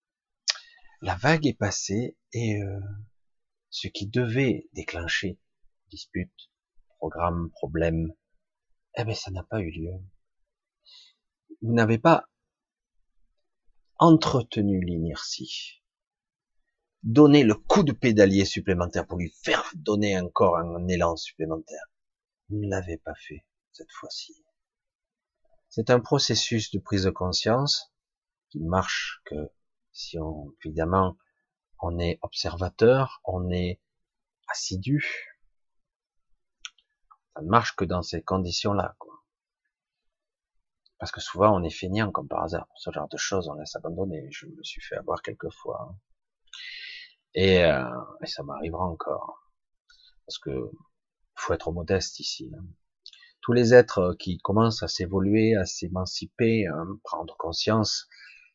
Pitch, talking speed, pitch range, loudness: 105 Hz, 125 wpm, 90-135 Hz, -26 LUFS